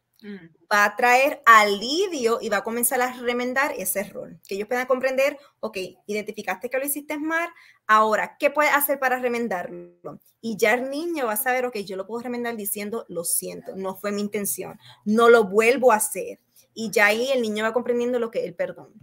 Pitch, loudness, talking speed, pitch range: 230 Hz, -22 LUFS, 200 wpm, 205-255 Hz